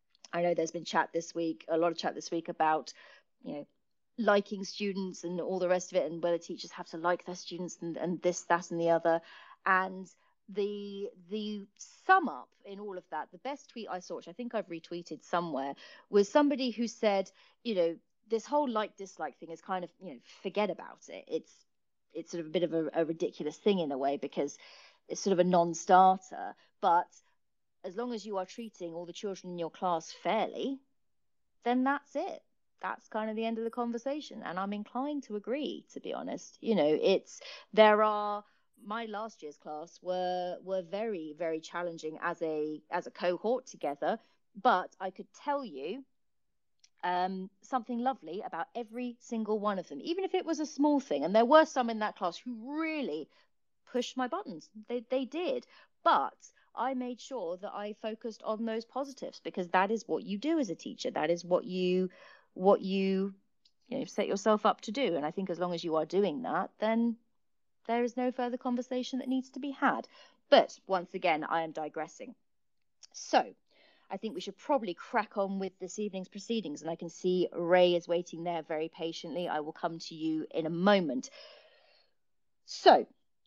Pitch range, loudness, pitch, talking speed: 175-240 Hz, -33 LUFS, 200 Hz, 200 wpm